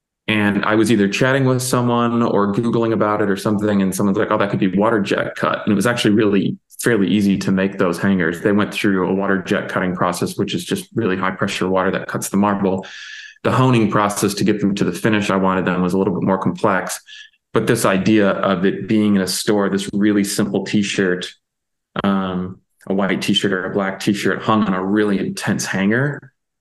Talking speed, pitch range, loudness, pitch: 230 wpm, 95-110 Hz, -18 LUFS, 100 Hz